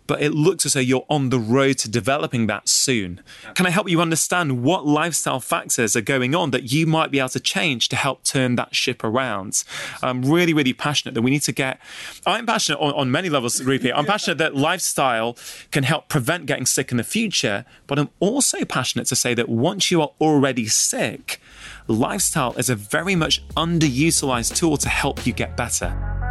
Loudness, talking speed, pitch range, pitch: -20 LUFS, 205 wpm, 125-160 Hz, 135 Hz